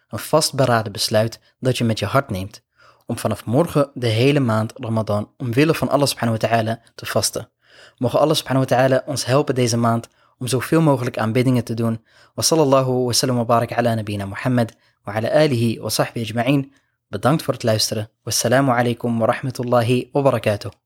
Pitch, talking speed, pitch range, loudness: 120 Hz, 175 wpm, 115-135 Hz, -19 LUFS